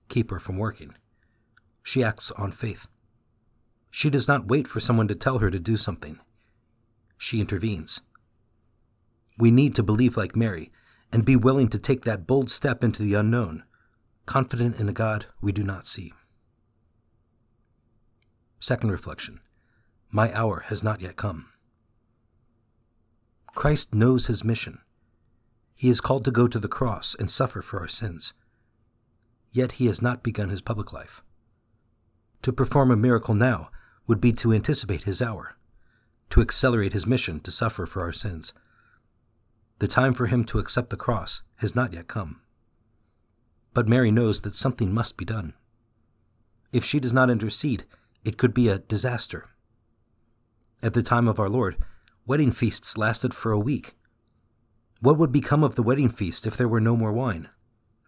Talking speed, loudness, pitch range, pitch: 160 wpm, -24 LUFS, 105-120 Hz, 115 Hz